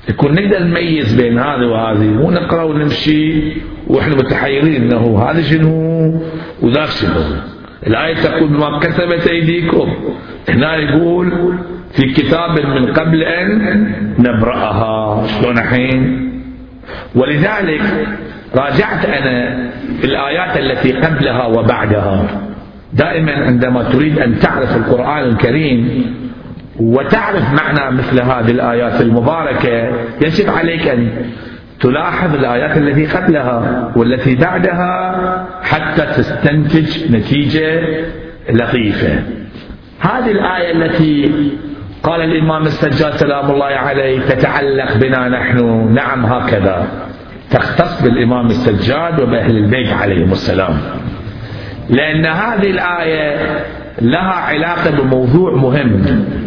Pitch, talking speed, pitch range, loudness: 140 Hz, 95 wpm, 120-160 Hz, -13 LUFS